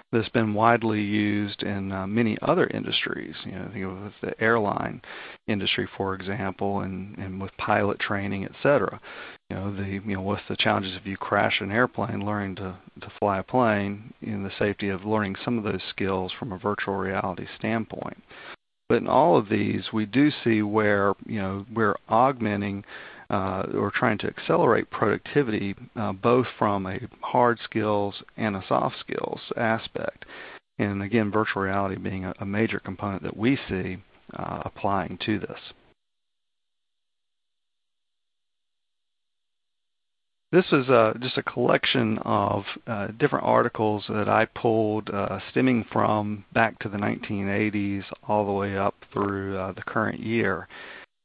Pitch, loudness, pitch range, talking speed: 105 Hz, -26 LUFS, 100-110 Hz, 155 wpm